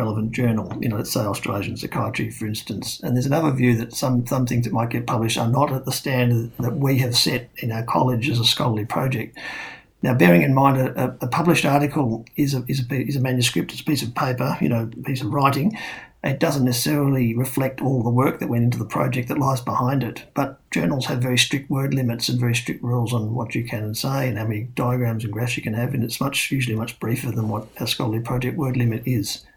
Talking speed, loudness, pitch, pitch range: 240 wpm, -22 LUFS, 125 Hz, 115-135 Hz